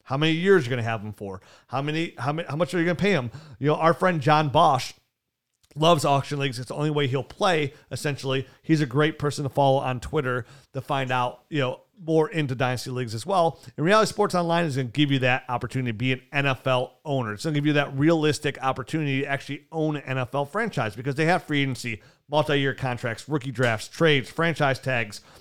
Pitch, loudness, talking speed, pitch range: 140 Hz, -24 LUFS, 235 wpm, 130-155 Hz